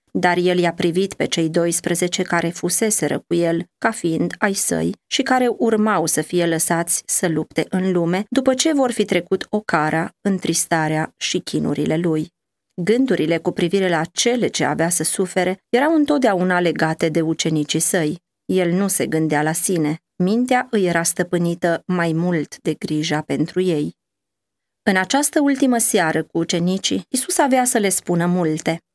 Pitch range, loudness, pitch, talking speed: 165-200 Hz, -19 LUFS, 175 Hz, 165 wpm